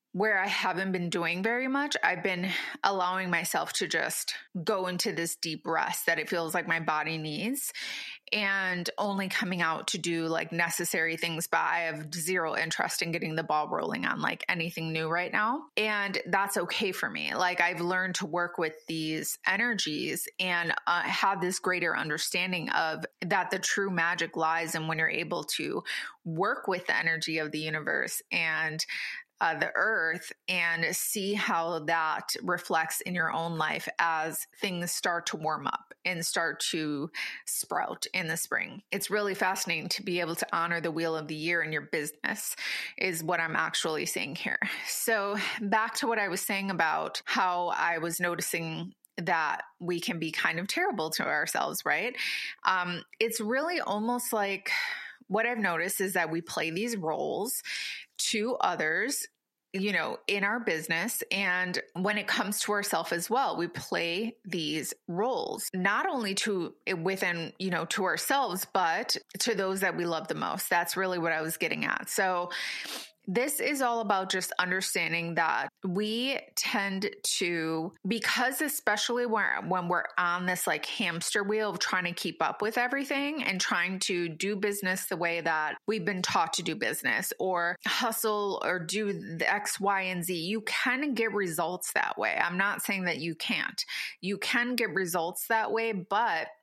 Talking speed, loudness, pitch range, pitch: 175 wpm, -30 LUFS, 165-205 Hz, 185 Hz